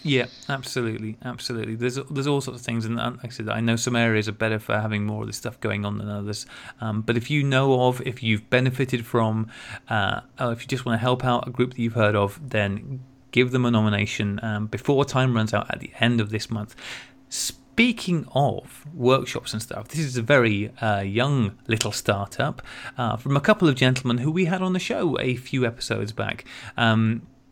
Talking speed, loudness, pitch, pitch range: 220 wpm, -24 LUFS, 120 Hz, 110-130 Hz